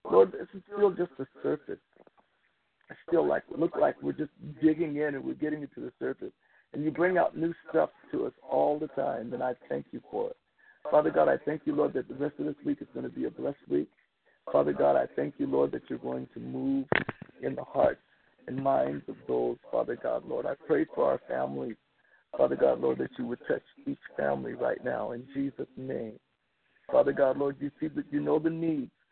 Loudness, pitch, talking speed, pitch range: -30 LUFS, 145 Hz, 225 wpm, 120-165 Hz